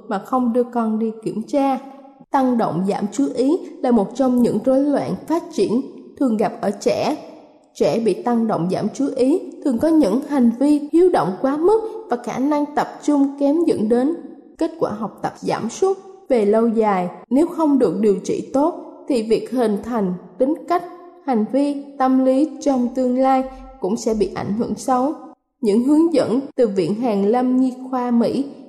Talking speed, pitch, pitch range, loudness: 190 wpm, 260 Hz, 230-290 Hz, -19 LUFS